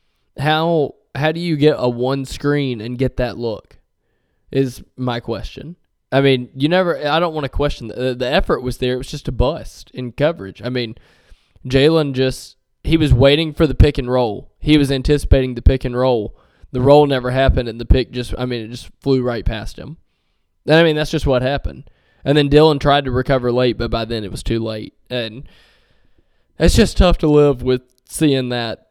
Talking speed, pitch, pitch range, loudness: 210 wpm, 130 Hz, 125-145 Hz, -17 LUFS